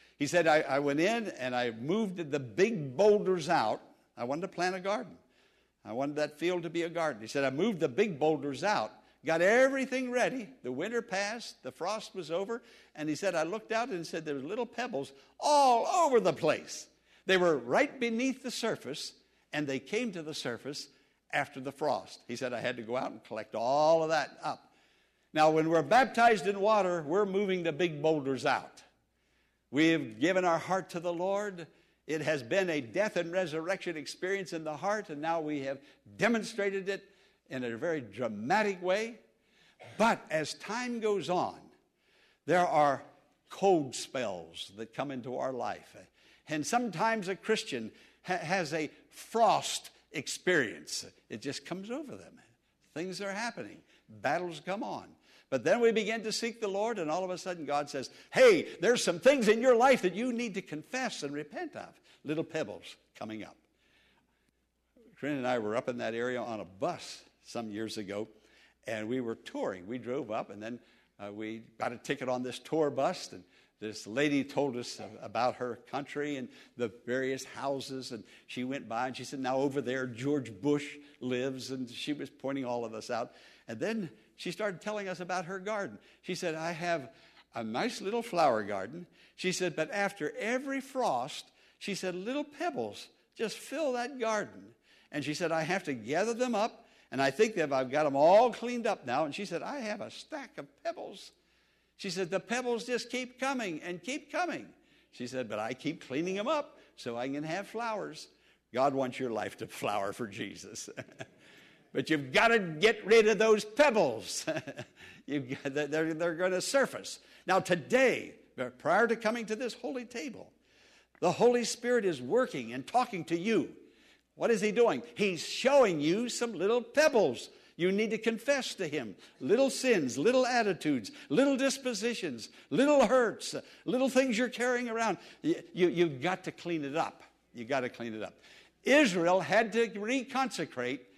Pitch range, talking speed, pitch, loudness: 140-230 Hz, 185 wpm, 180 Hz, -32 LUFS